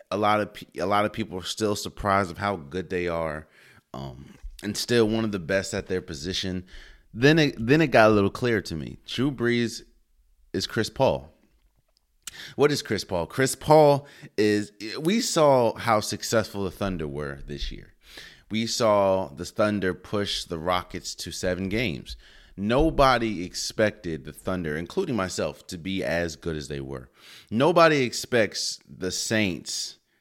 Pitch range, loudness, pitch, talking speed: 90-115 Hz, -25 LUFS, 100 Hz, 165 wpm